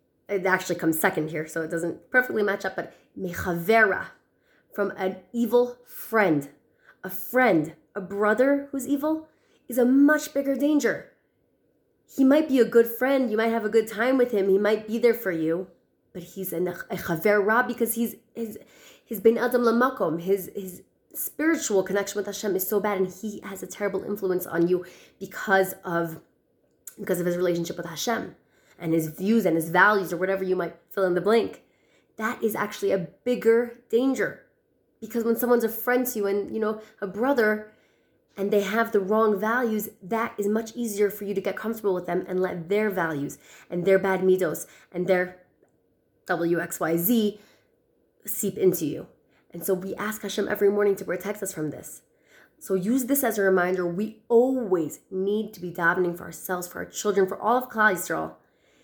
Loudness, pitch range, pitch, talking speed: -25 LUFS, 180-230 Hz, 205 Hz, 185 wpm